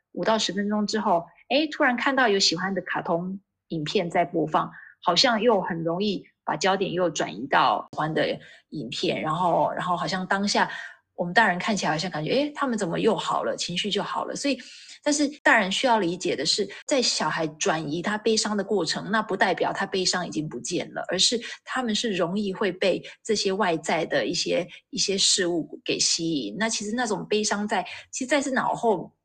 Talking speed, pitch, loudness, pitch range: 300 characters per minute, 200 Hz, -24 LUFS, 180-225 Hz